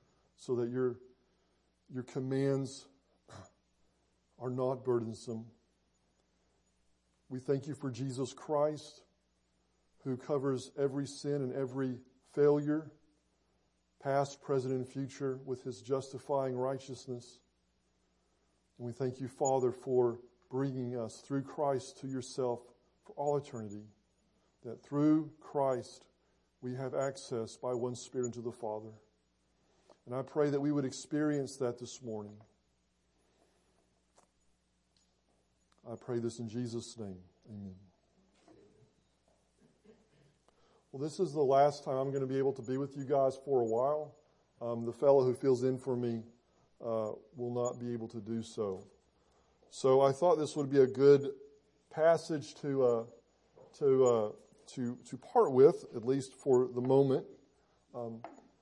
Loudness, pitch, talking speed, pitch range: -34 LUFS, 125 Hz, 135 wpm, 110-135 Hz